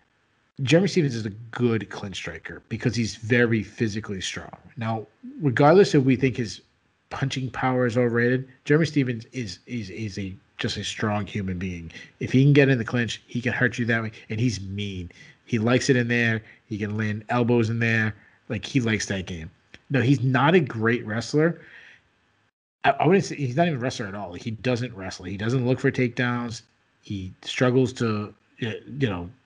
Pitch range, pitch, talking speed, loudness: 105-130 Hz, 120 Hz, 195 wpm, -24 LUFS